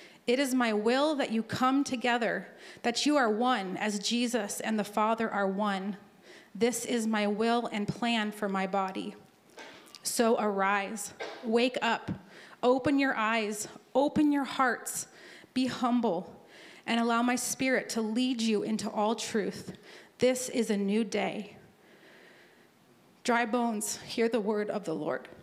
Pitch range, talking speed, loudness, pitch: 210-245 Hz, 150 wpm, -30 LUFS, 230 Hz